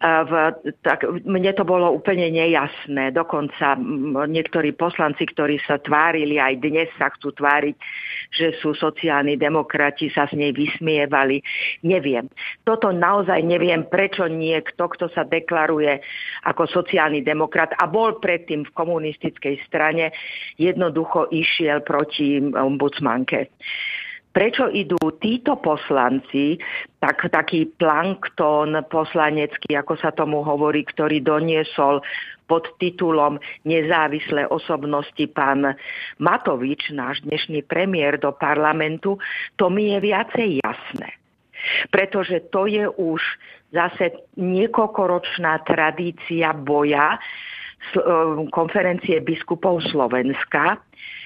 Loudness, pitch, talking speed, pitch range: -20 LUFS, 160 Hz, 105 wpm, 150-175 Hz